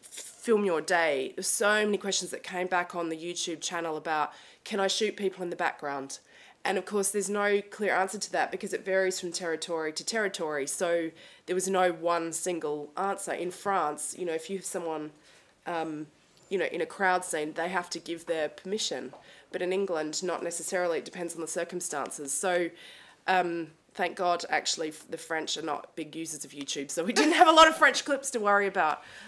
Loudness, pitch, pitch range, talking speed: -29 LUFS, 175 Hz, 160-195 Hz, 205 wpm